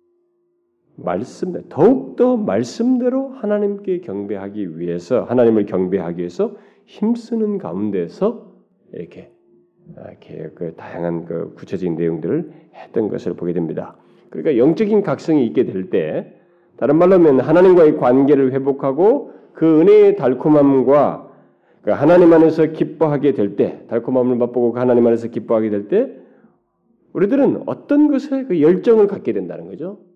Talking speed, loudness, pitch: 310 characters per minute, -16 LUFS, 150 Hz